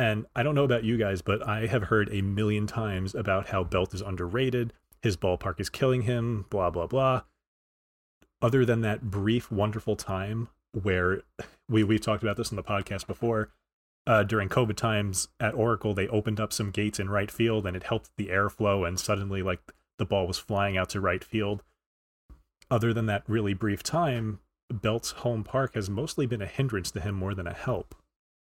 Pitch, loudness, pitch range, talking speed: 105 Hz, -29 LUFS, 100-115 Hz, 195 wpm